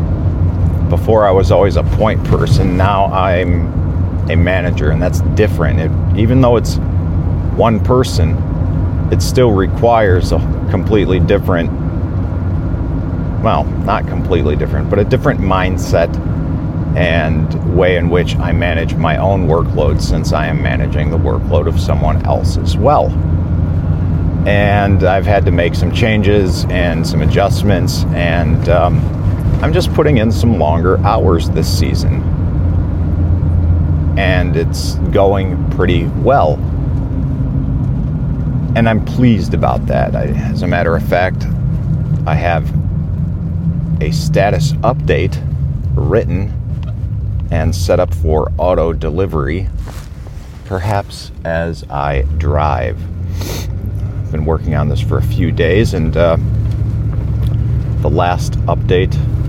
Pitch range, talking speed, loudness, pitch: 85-100 Hz, 120 wpm, -14 LUFS, 90 Hz